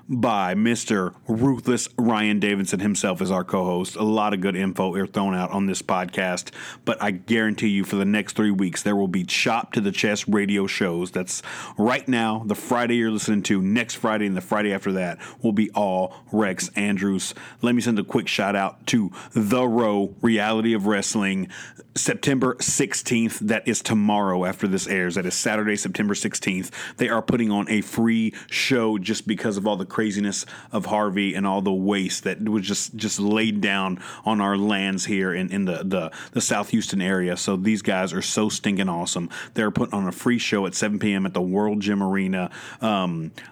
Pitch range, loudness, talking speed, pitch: 95-110 Hz, -23 LUFS, 200 wpm, 105 Hz